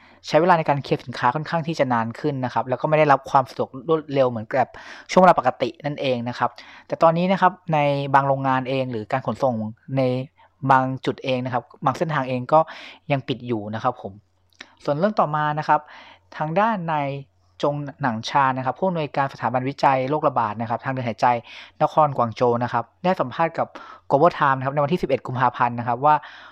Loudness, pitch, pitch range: -22 LUFS, 135 Hz, 125-150 Hz